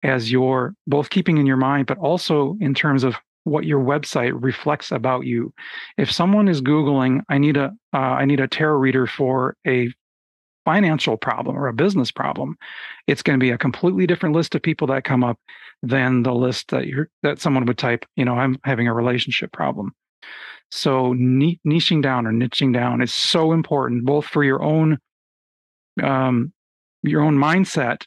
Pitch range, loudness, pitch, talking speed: 125-155 Hz, -20 LUFS, 135 Hz, 180 wpm